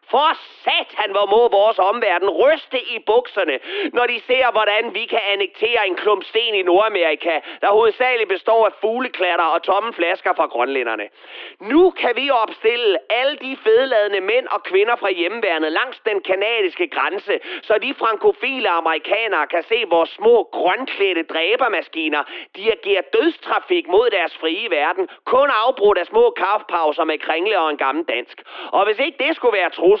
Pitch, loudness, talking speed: 285 Hz, -18 LUFS, 165 wpm